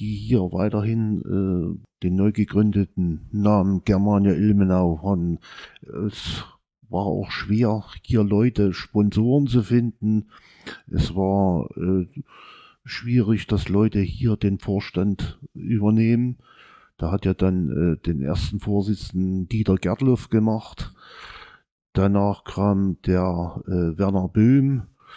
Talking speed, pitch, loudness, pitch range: 110 wpm, 100 Hz, -22 LUFS, 95-110 Hz